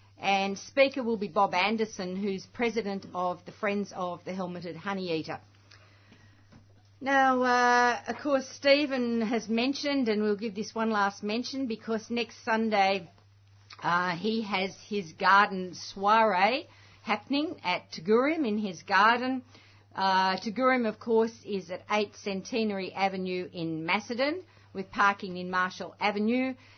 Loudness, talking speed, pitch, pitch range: -28 LUFS, 135 wpm, 205 Hz, 180-230 Hz